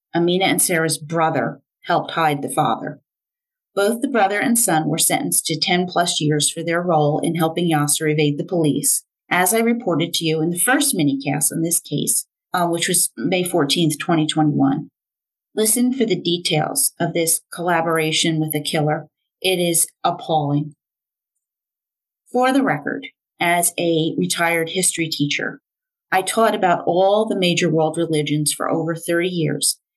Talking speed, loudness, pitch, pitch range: 160 wpm, -19 LUFS, 170 Hz, 155-180 Hz